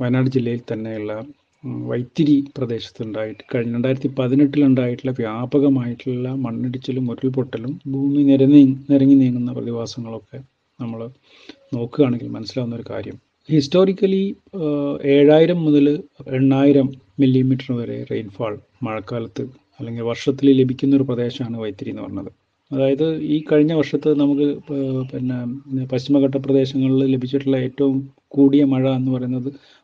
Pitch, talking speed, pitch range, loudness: 135 Hz, 105 wpm, 125-140 Hz, -19 LUFS